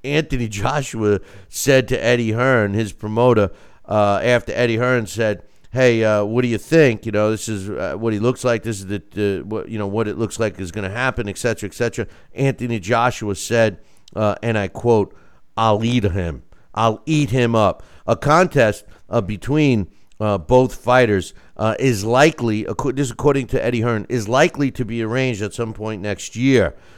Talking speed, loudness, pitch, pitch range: 195 wpm, -19 LUFS, 115 Hz, 105-125 Hz